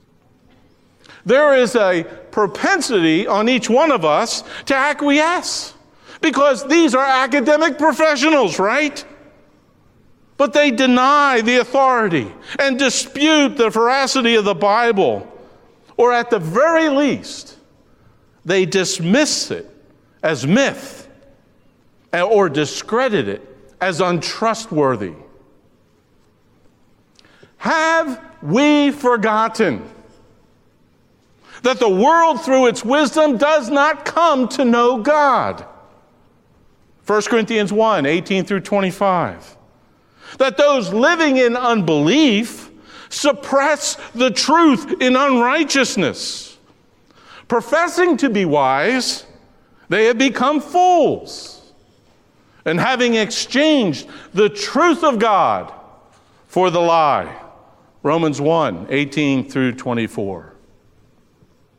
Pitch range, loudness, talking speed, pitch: 200-290 Hz, -16 LUFS, 95 wpm, 255 Hz